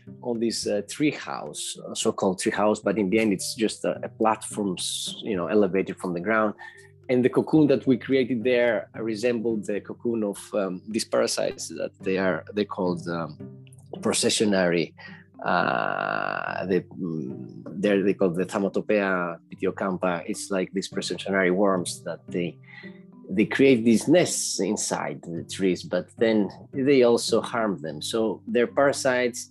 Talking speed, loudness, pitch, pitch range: 155 wpm, -25 LUFS, 105 Hz, 95-120 Hz